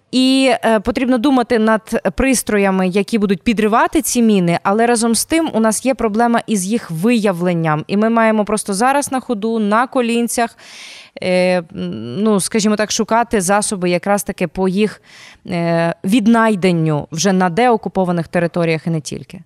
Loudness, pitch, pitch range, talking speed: -15 LUFS, 215 Hz, 185-235 Hz, 145 wpm